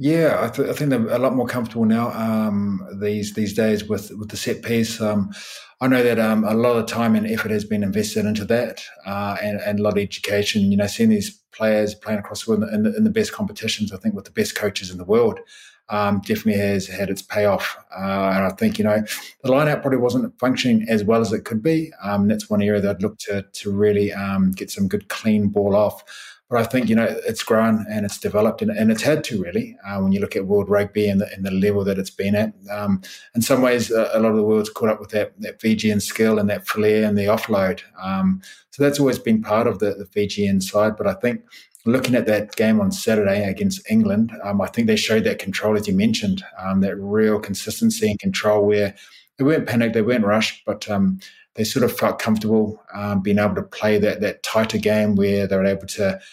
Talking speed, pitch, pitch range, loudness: 240 wpm, 105 Hz, 100-120 Hz, -20 LUFS